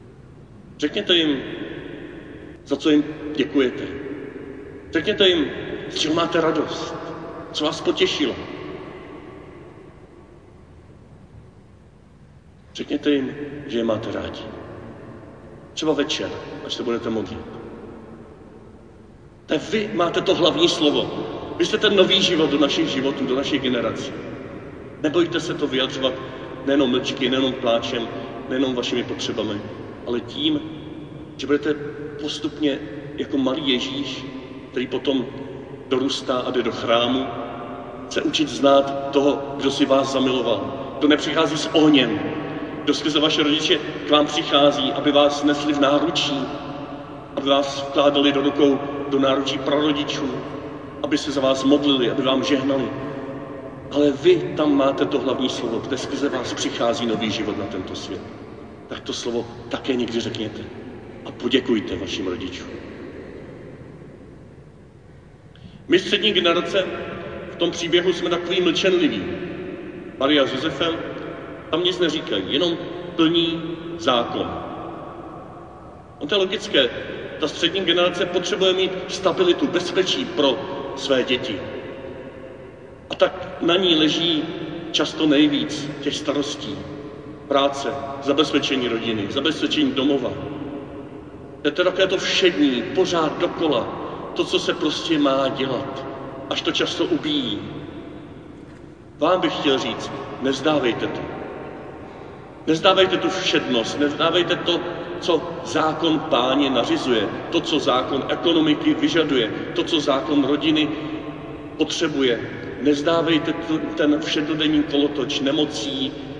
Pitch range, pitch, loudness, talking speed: 135-165 Hz, 145 Hz, -21 LUFS, 120 wpm